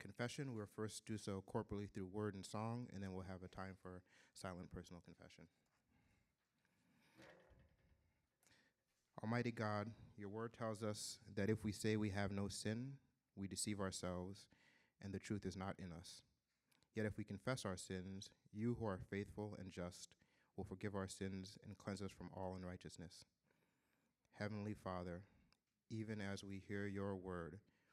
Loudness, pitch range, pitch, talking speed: -49 LUFS, 95-110 Hz, 100 Hz, 160 wpm